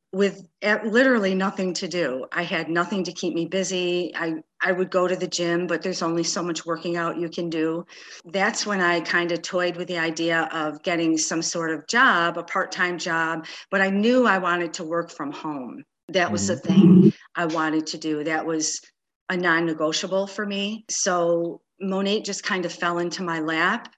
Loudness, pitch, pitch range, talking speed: -23 LUFS, 175 Hz, 165-190 Hz, 200 wpm